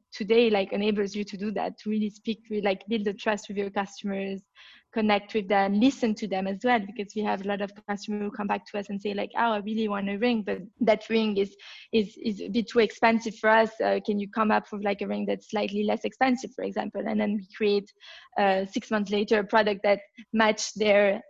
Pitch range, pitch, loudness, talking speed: 200-220 Hz, 210 Hz, -27 LUFS, 245 wpm